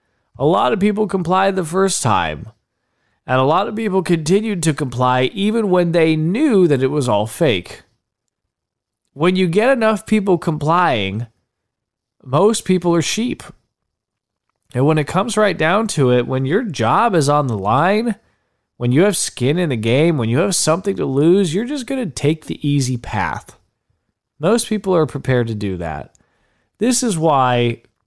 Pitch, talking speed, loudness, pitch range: 160 Hz, 175 wpm, -17 LUFS, 125-195 Hz